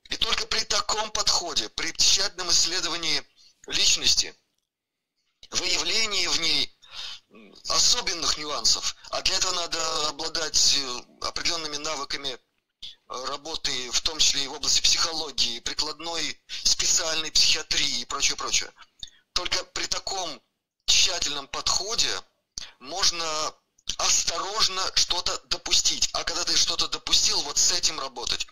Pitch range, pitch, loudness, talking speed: 150-175 Hz, 160 Hz, -23 LUFS, 110 wpm